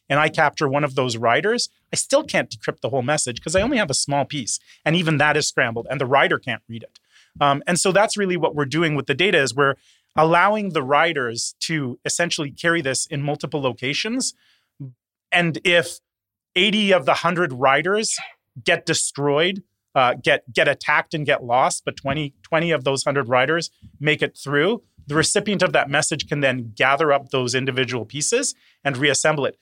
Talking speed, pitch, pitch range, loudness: 195 wpm, 150 Hz, 135-170 Hz, -20 LUFS